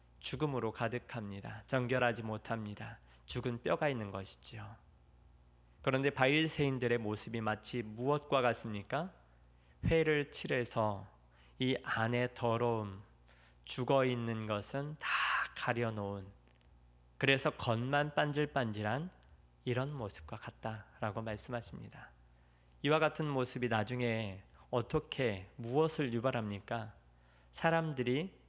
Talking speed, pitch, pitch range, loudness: 255 characters per minute, 115 Hz, 100-130 Hz, -36 LUFS